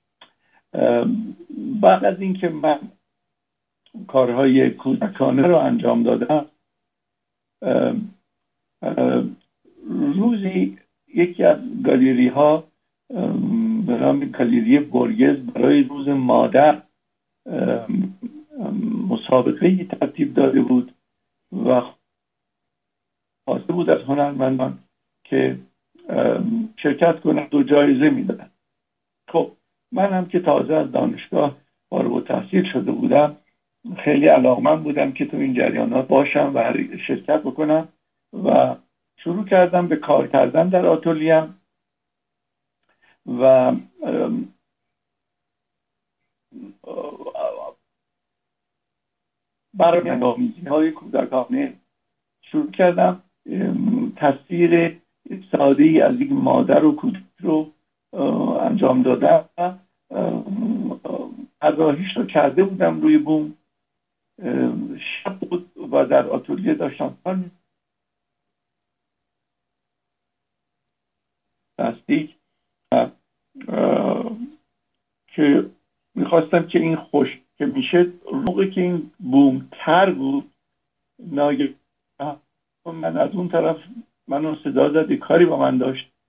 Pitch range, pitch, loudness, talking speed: 150-255 Hz, 185 Hz, -19 LUFS, 85 wpm